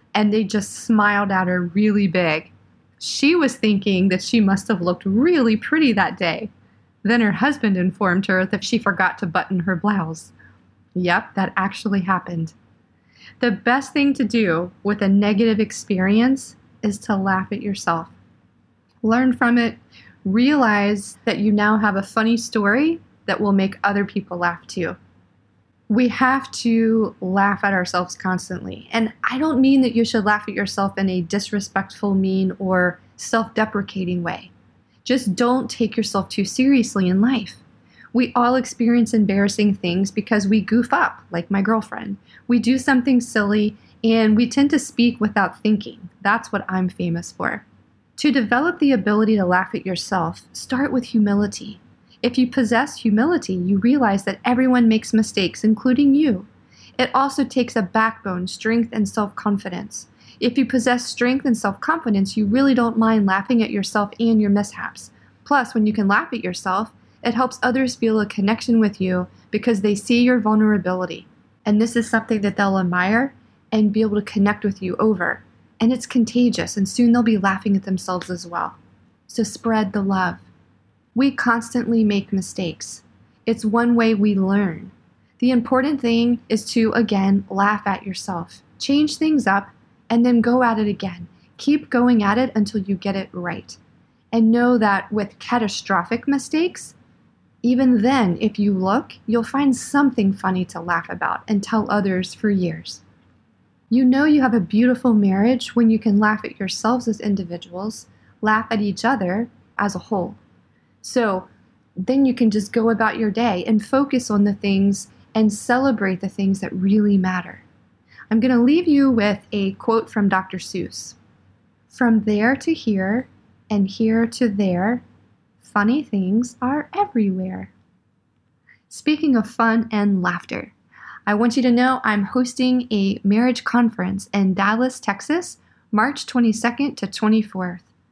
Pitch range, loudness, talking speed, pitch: 195-240 Hz, -19 LUFS, 165 wpm, 215 Hz